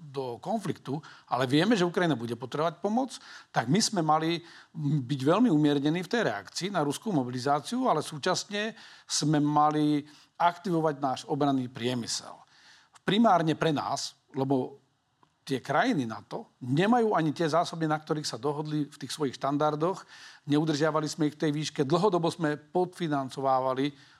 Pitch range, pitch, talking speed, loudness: 140-170 Hz, 150 Hz, 145 wpm, -28 LUFS